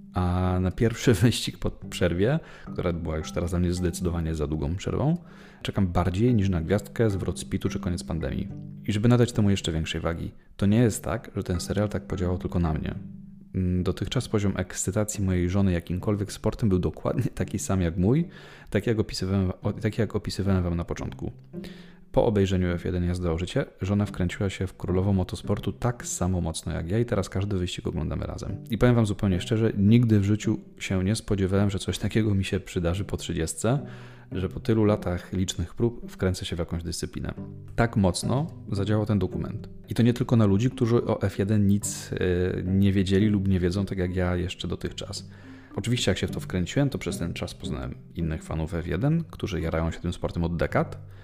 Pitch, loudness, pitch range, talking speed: 95 Hz, -27 LUFS, 90-110 Hz, 195 wpm